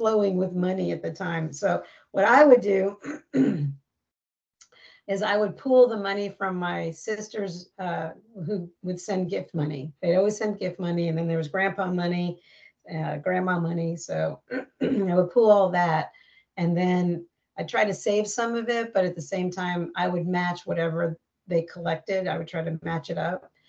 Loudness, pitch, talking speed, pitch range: -26 LUFS, 180 Hz, 185 wpm, 165-200 Hz